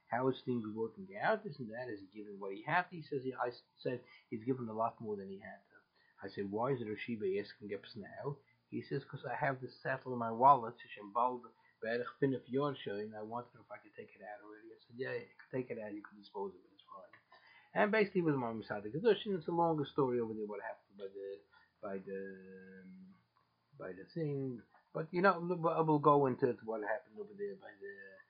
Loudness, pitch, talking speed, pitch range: -38 LUFS, 125 Hz, 235 wpm, 105-150 Hz